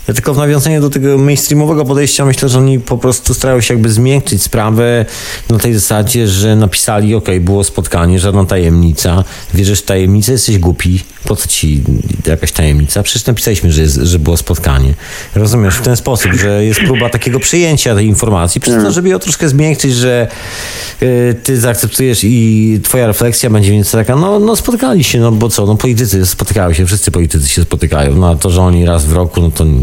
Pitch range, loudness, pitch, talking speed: 90-125 Hz, -10 LUFS, 110 Hz, 195 wpm